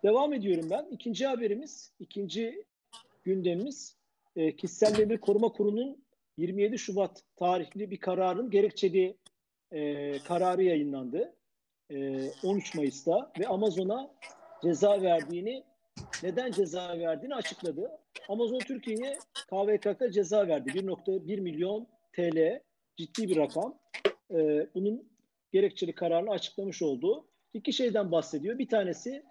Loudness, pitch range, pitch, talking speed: -31 LUFS, 175-240 Hz, 200 Hz, 110 wpm